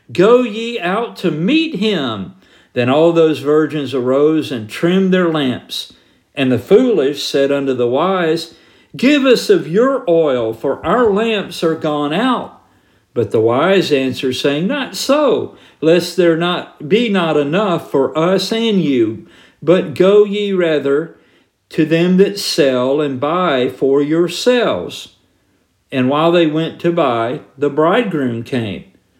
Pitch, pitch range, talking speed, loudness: 165 Hz, 140-195 Hz, 145 wpm, -15 LUFS